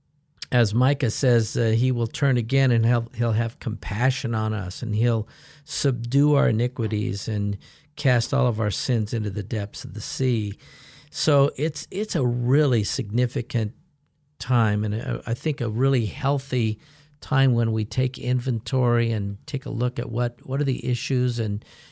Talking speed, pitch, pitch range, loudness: 165 wpm, 125 Hz, 115-135 Hz, -24 LUFS